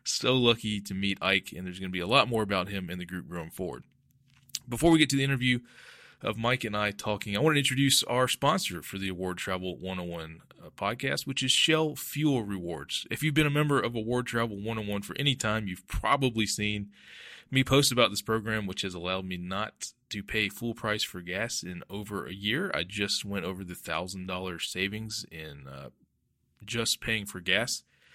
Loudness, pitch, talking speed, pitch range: -29 LUFS, 105 Hz, 205 wpm, 95-125 Hz